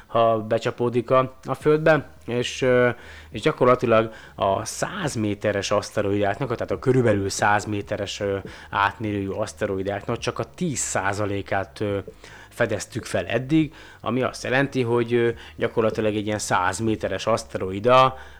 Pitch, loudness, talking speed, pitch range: 110 Hz, -23 LUFS, 115 wpm, 100-125 Hz